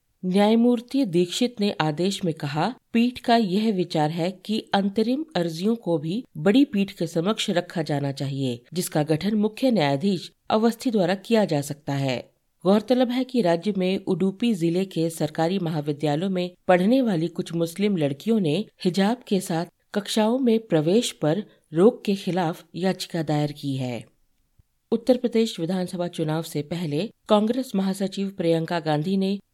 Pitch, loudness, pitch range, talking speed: 185 Hz, -24 LUFS, 165-215 Hz, 150 wpm